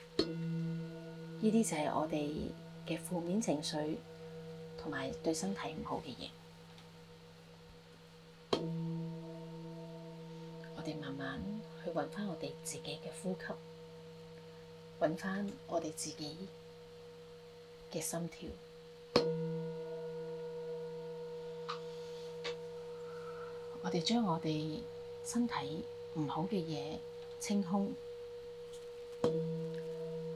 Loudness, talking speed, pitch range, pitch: -40 LUFS, 110 characters per minute, 160-205 Hz, 160 Hz